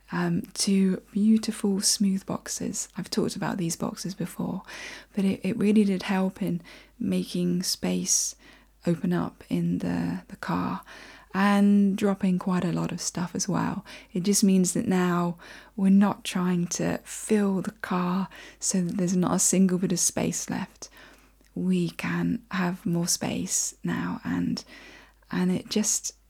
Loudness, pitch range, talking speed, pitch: -26 LUFS, 180-205 Hz, 155 wpm, 190 Hz